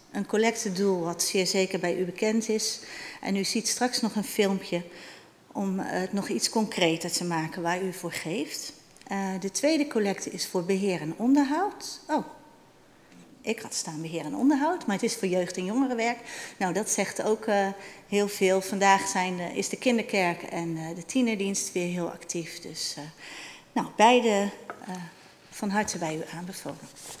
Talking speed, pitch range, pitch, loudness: 175 wpm, 180-220 Hz, 195 Hz, -28 LUFS